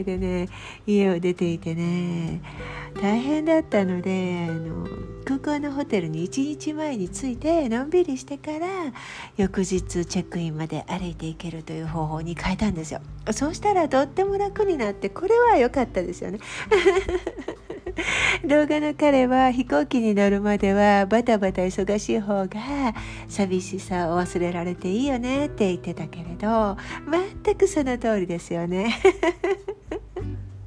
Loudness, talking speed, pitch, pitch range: -24 LUFS, 290 characters per minute, 205 Hz, 175-295 Hz